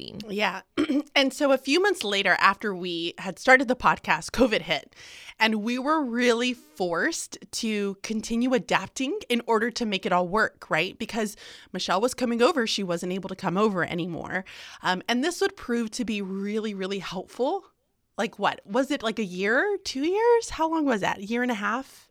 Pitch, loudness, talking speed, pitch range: 225 Hz, -25 LUFS, 195 wpm, 190-260 Hz